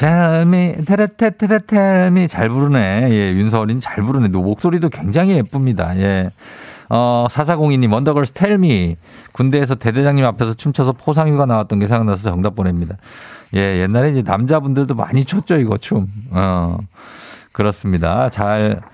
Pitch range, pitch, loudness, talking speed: 105-155 Hz, 120 Hz, -15 LUFS, 325 characters per minute